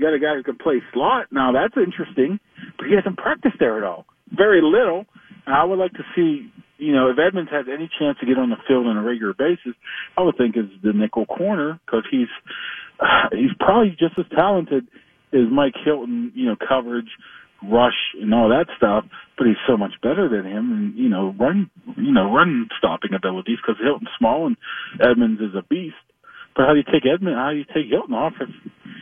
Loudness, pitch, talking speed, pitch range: -20 LUFS, 160 Hz, 215 wpm, 130-210 Hz